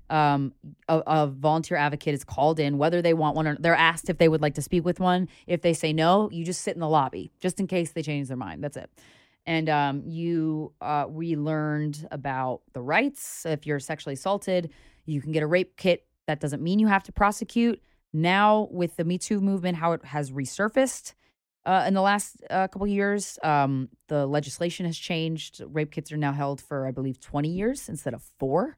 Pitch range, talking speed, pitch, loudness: 150-180 Hz, 215 wpm, 160 Hz, -26 LUFS